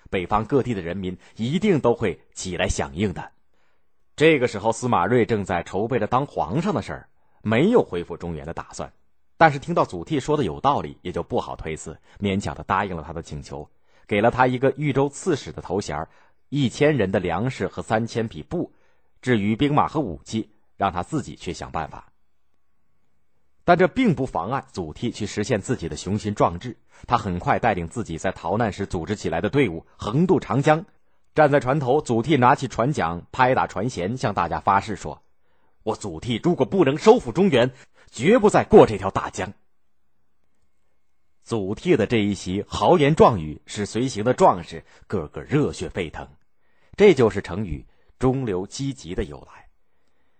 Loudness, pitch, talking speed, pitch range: -22 LUFS, 105 Hz, 265 characters per minute, 85-130 Hz